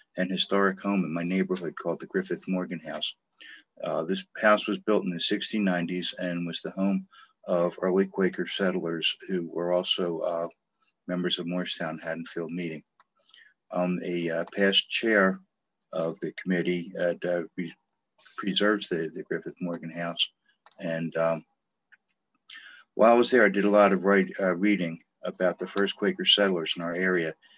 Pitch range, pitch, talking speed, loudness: 85-95 Hz, 90 Hz, 165 wpm, -27 LUFS